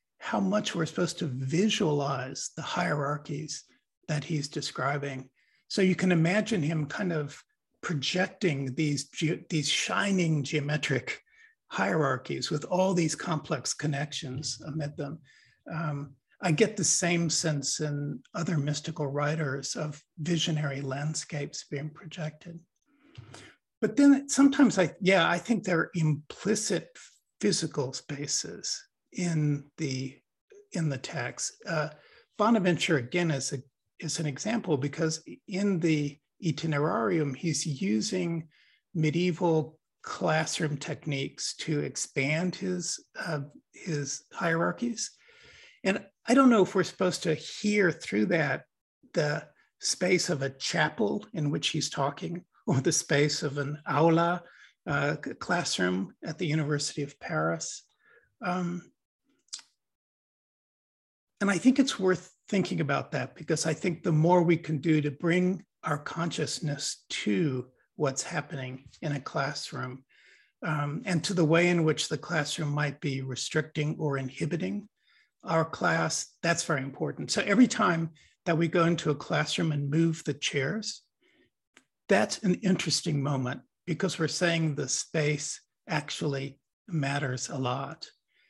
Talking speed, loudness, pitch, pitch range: 130 wpm, -29 LUFS, 160 Hz, 145-180 Hz